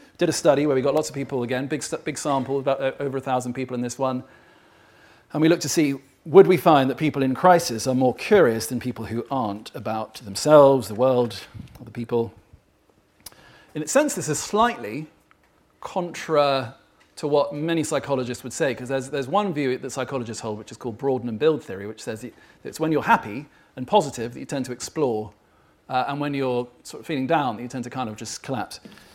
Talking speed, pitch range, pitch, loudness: 215 wpm, 120-150 Hz, 135 Hz, -23 LUFS